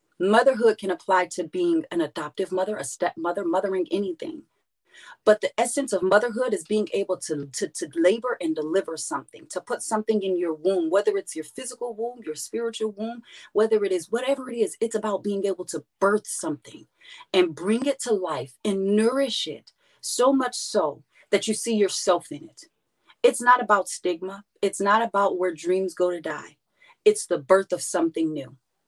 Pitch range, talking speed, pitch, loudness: 185-240 Hz, 185 wpm, 205 Hz, -25 LUFS